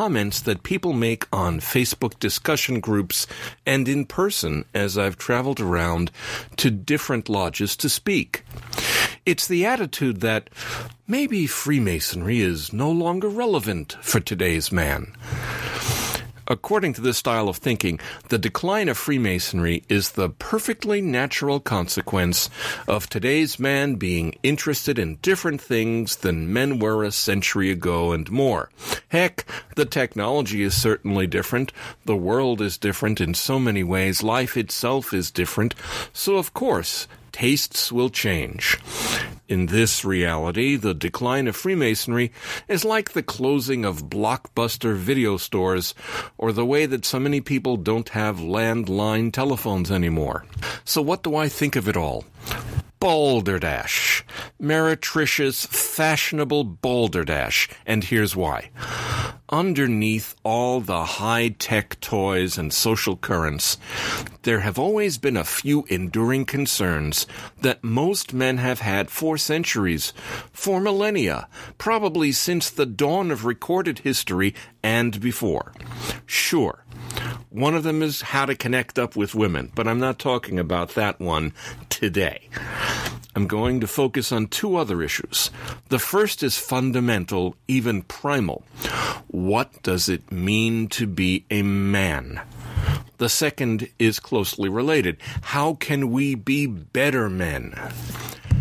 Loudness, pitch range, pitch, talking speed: -23 LUFS, 100-135 Hz, 115 Hz, 130 wpm